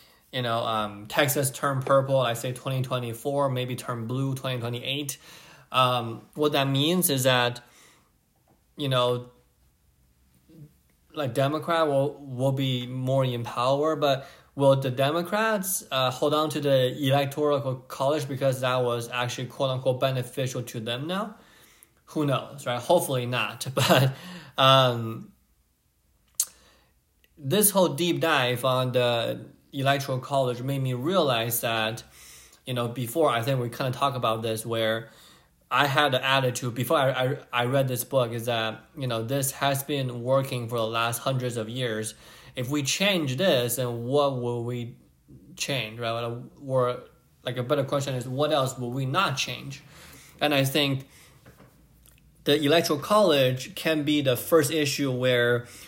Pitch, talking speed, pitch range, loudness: 130 Hz, 155 wpm, 120-140 Hz, -26 LUFS